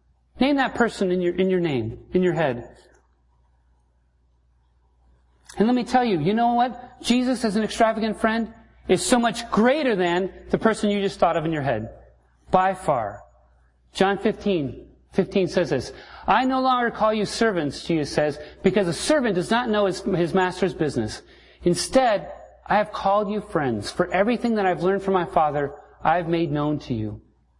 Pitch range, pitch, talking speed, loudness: 140-220 Hz, 185 Hz, 180 wpm, -23 LUFS